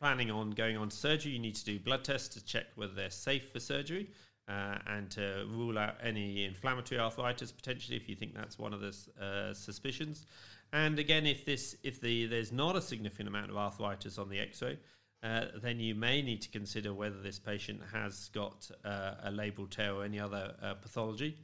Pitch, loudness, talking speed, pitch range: 110 Hz, -38 LUFS, 205 wpm, 100-125 Hz